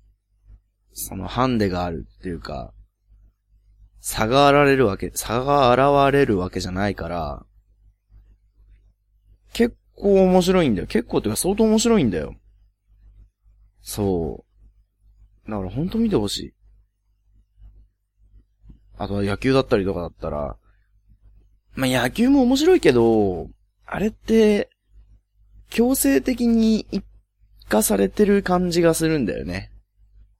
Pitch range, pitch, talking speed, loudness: 100-135 Hz, 100 Hz, 230 characters per minute, -20 LUFS